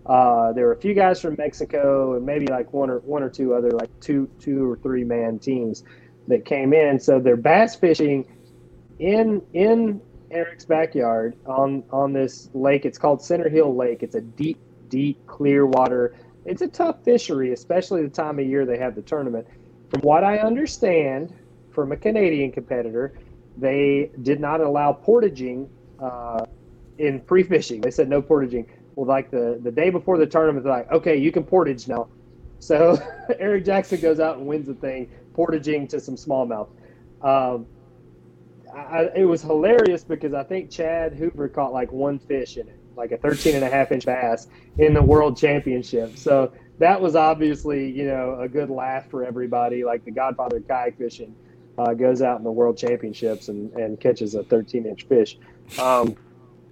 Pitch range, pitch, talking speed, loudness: 125-160 Hz, 140 Hz, 180 wpm, -21 LUFS